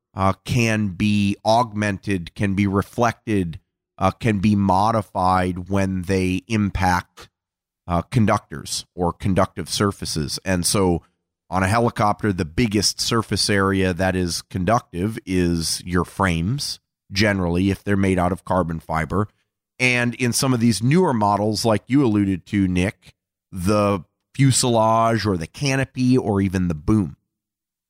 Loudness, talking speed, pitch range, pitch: -21 LUFS, 135 wpm, 90-110 Hz, 100 Hz